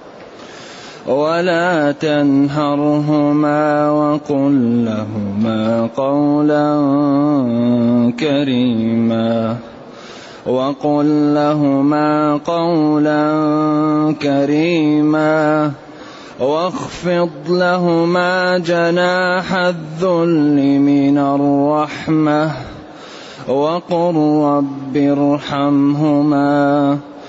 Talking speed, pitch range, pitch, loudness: 40 wpm, 140-155 Hz, 150 Hz, -15 LUFS